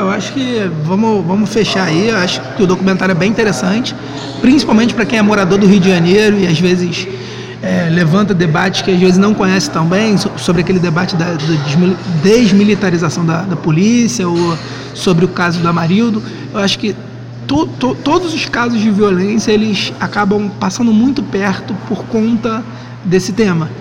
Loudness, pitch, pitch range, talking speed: -12 LUFS, 190 Hz, 175-215 Hz, 175 wpm